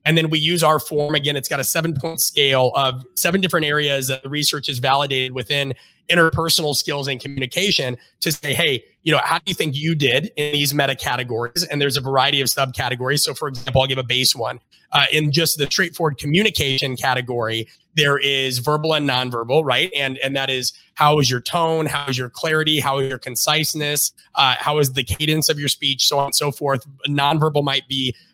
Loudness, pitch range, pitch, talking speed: -19 LUFS, 130-155 Hz, 140 Hz, 215 wpm